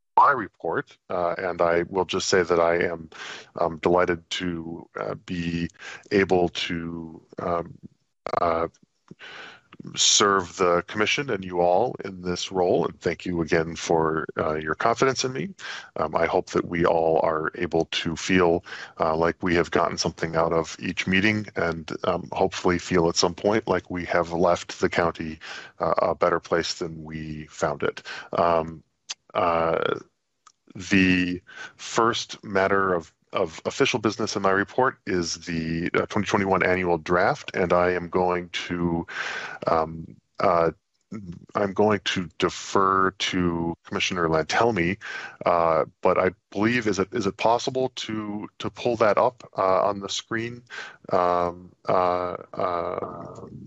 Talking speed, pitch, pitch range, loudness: 150 wpm, 90 Hz, 85-95 Hz, -24 LUFS